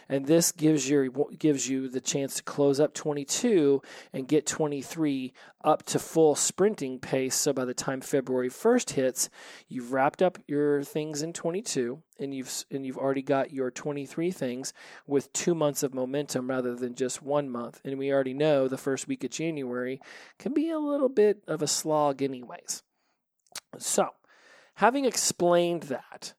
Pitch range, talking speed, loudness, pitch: 130-160 Hz, 170 wpm, -28 LUFS, 145 Hz